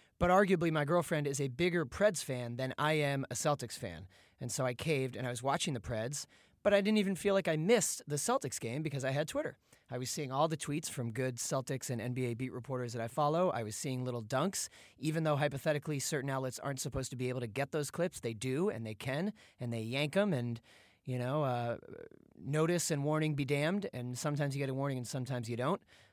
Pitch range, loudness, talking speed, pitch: 125-155 Hz, -35 LUFS, 235 wpm, 140 Hz